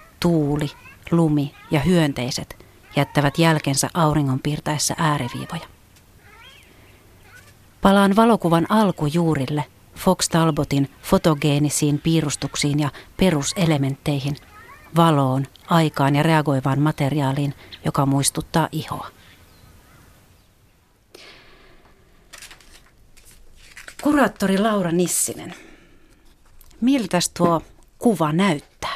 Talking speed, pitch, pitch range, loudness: 65 wpm, 150 Hz, 135-165 Hz, -20 LUFS